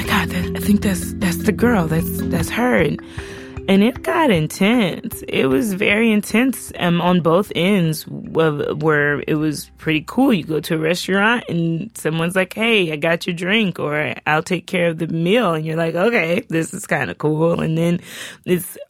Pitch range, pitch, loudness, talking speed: 160-205 Hz, 175 Hz, -18 LUFS, 195 wpm